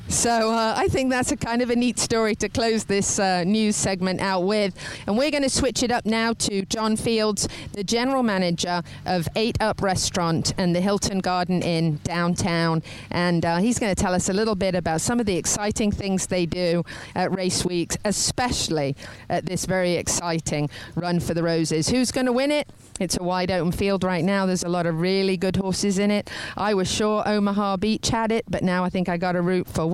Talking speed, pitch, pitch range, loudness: 220 wpm, 190 Hz, 175-215 Hz, -23 LUFS